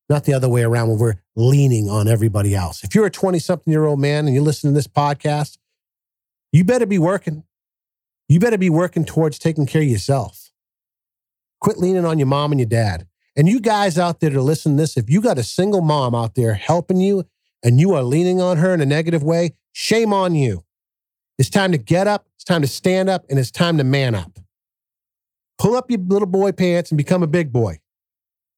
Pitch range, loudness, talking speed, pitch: 120-180 Hz, -17 LUFS, 220 wpm, 150 Hz